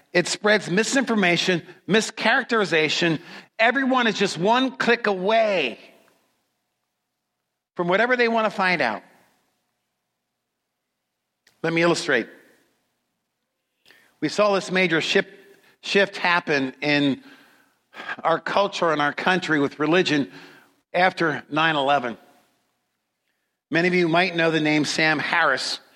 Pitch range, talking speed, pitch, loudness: 155-210 Hz, 105 wpm, 180 Hz, -21 LUFS